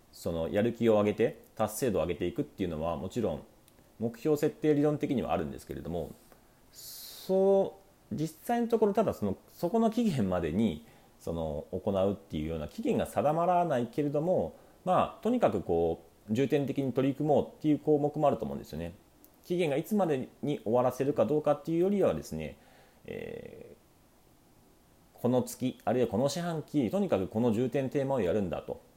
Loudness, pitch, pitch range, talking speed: -31 LUFS, 140 Hz, 110-175 Hz, 375 characters per minute